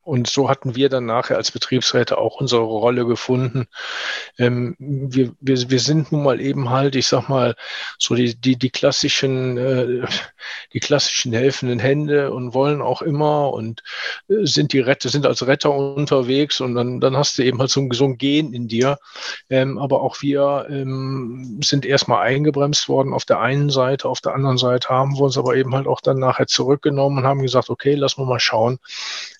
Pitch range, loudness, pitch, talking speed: 125-140 Hz, -19 LUFS, 135 Hz, 190 wpm